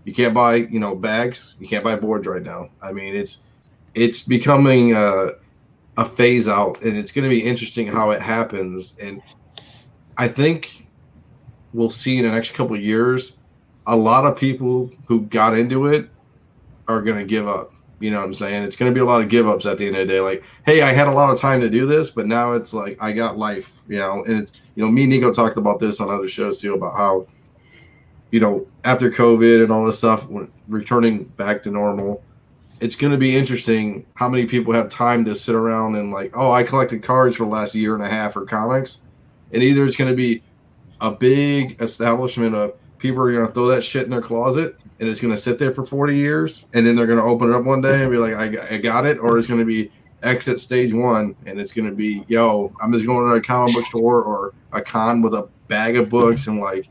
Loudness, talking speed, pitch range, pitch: -18 LUFS, 235 wpm, 110-125 Hz, 115 Hz